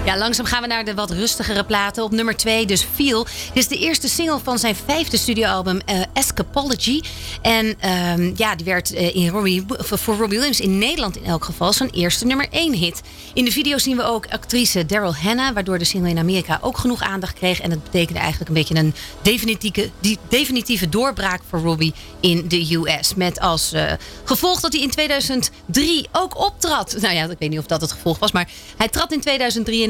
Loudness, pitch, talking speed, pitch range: -19 LUFS, 220 Hz, 210 wpm, 180-255 Hz